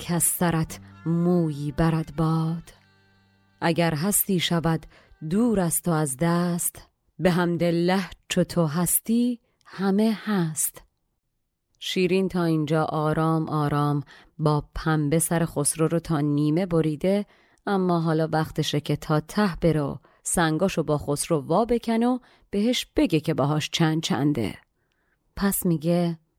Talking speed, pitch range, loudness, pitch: 125 wpm, 155-180 Hz, -24 LUFS, 165 Hz